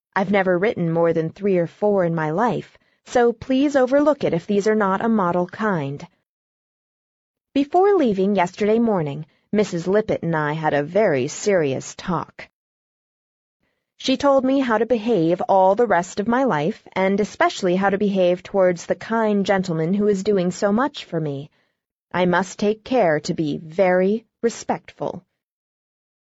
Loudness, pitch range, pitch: -20 LUFS, 175-225 Hz, 200 Hz